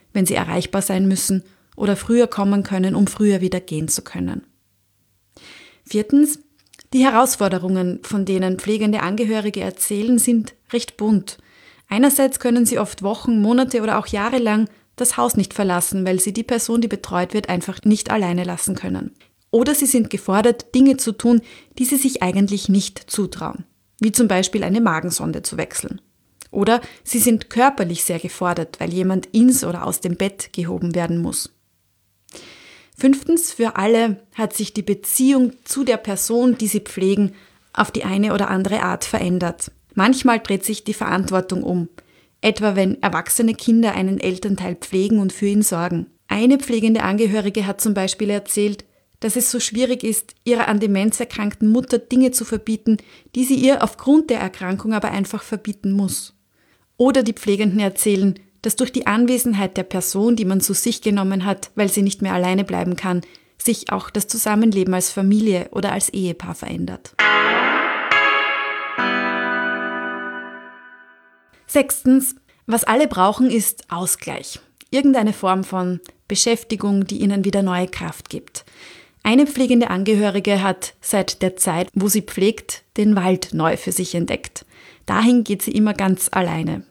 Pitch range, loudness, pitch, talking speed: 185-230 Hz, -19 LUFS, 205 Hz, 155 wpm